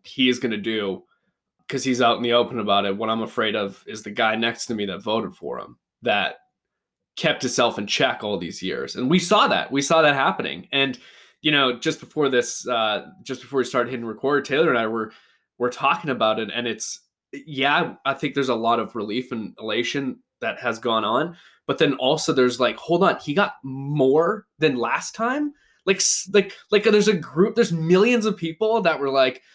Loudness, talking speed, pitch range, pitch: -22 LUFS, 215 wpm, 115-165 Hz, 130 Hz